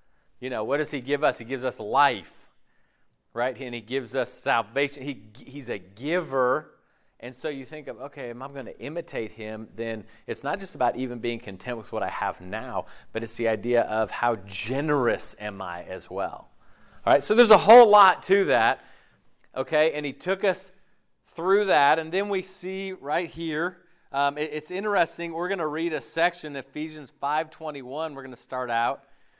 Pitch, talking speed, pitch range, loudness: 140 Hz, 195 wpm, 120-165 Hz, -25 LUFS